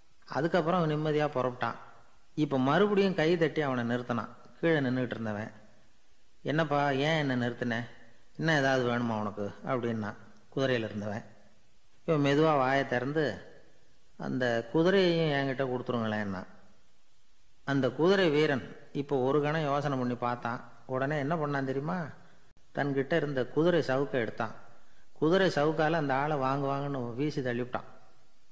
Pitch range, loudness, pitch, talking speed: 120-150 Hz, -30 LUFS, 135 Hz, 120 wpm